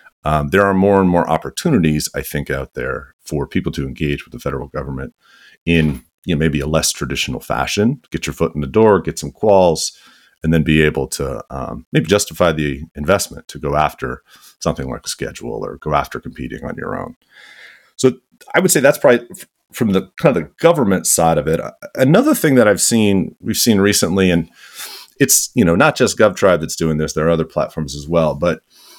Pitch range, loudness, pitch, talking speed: 75-85 Hz, -16 LUFS, 80 Hz, 205 wpm